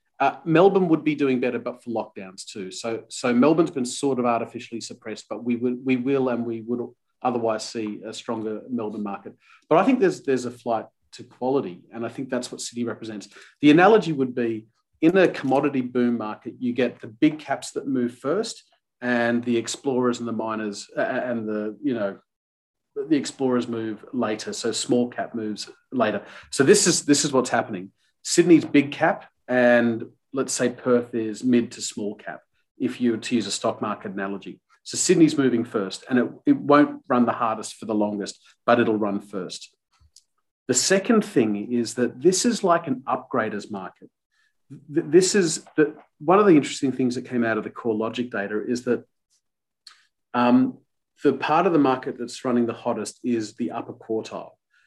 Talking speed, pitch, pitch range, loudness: 190 wpm, 120 Hz, 115-135 Hz, -23 LUFS